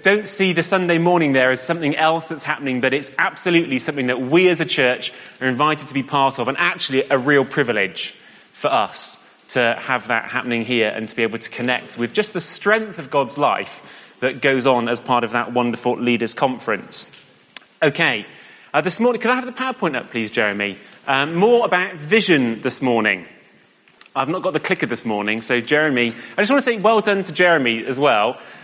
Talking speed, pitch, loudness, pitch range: 205 wpm, 135 Hz, -18 LUFS, 120-175 Hz